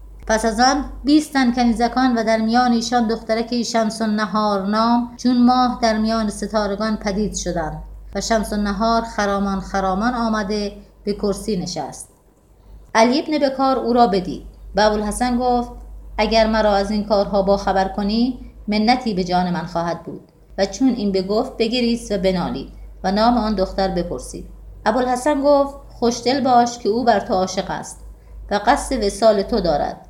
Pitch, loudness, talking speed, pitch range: 220 Hz, -19 LUFS, 160 wpm, 200-240 Hz